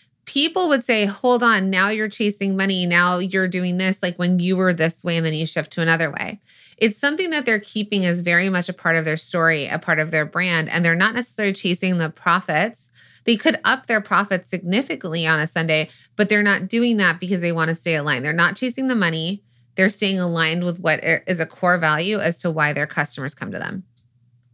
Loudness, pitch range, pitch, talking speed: -19 LUFS, 165-205 Hz, 180 Hz, 225 wpm